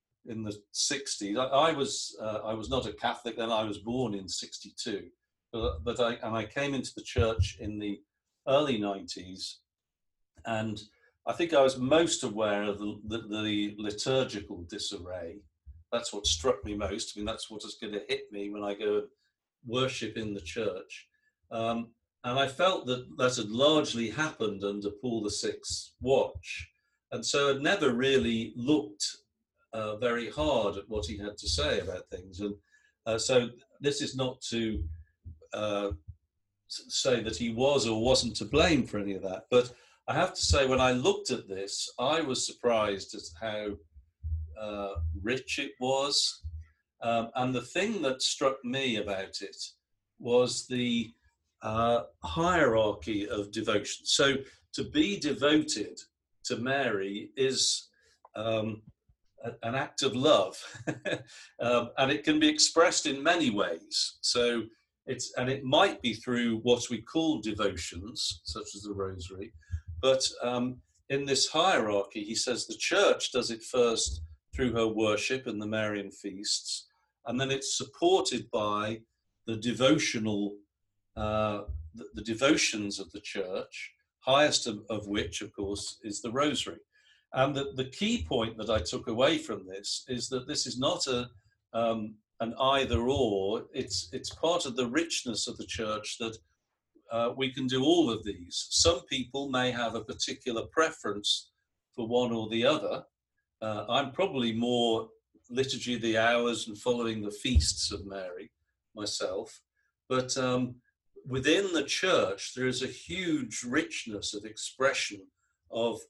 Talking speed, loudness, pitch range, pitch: 155 wpm, -30 LUFS, 100-130 Hz, 115 Hz